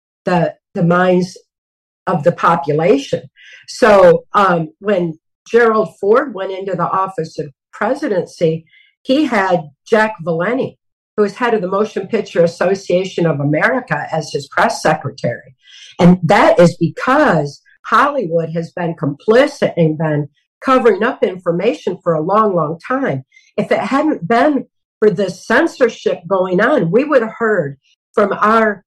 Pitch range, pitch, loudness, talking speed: 170-225 Hz, 190 Hz, -15 LUFS, 140 wpm